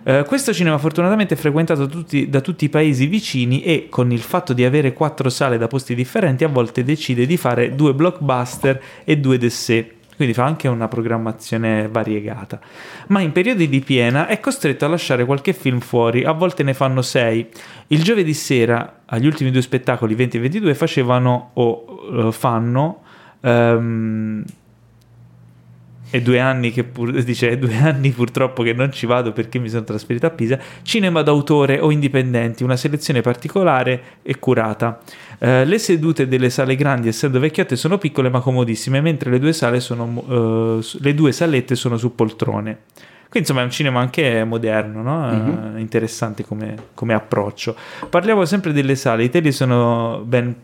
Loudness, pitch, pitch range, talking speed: -18 LUFS, 125 Hz, 115-150 Hz, 170 wpm